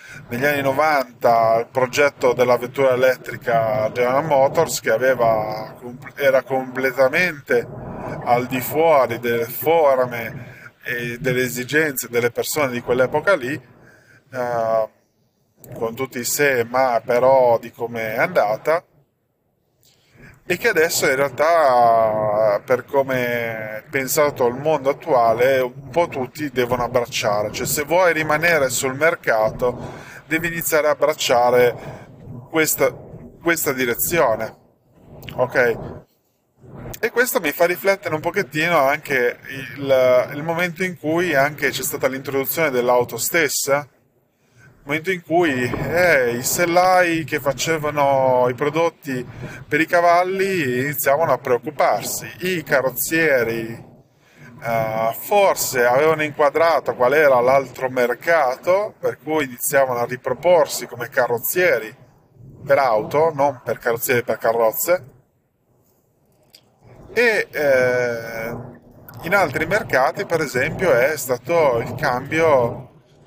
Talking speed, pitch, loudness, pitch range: 115 wpm, 130 Hz, -19 LUFS, 125-155 Hz